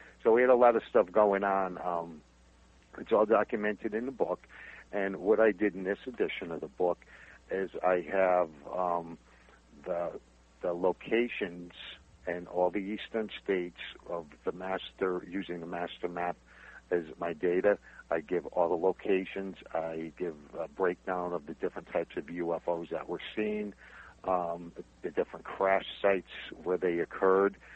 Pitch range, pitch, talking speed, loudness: 85-100 Hz, 90 Hz, 160 wpm, -32 LUFS